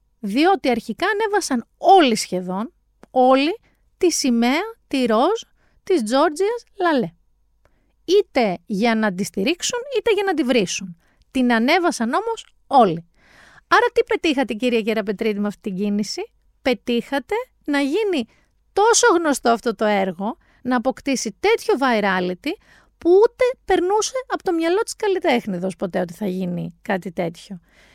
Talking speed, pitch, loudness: 135 wpm, 260 Hz, -20 LUFS